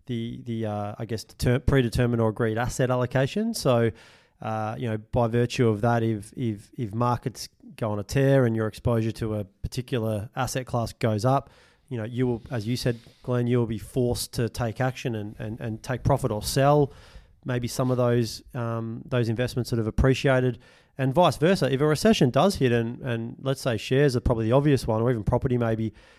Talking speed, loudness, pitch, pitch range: 205 wpm, -25 LUFS, 120 Hz, 115-130 Hz